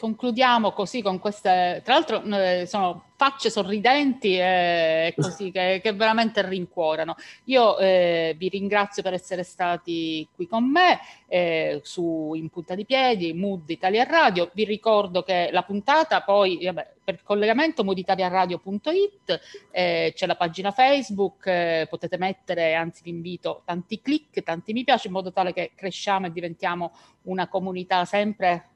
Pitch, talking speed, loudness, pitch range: 190 Hz, 150 wpm, -23 LUFS, 175-215 Hz